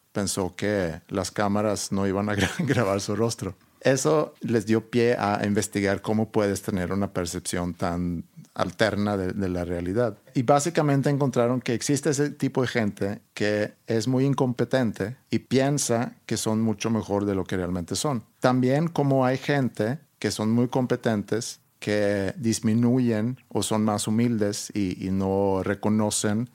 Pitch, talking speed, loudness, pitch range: 110 Hz, 155 wpm, -25 LUFS, 100-125 Hz